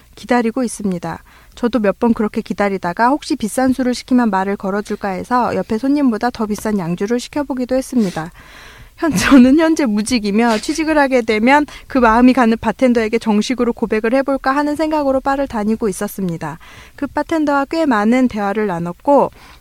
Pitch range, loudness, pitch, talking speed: 210-270 Hz, -16 LUFS, 240 Hz, 380 characters per minute